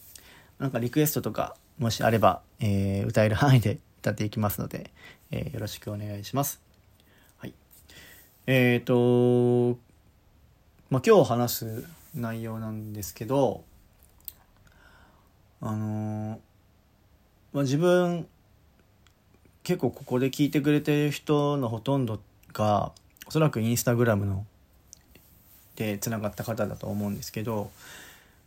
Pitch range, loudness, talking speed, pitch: 100-125 Hz, -27 LUFS, 250 characters per minute, 105 Hz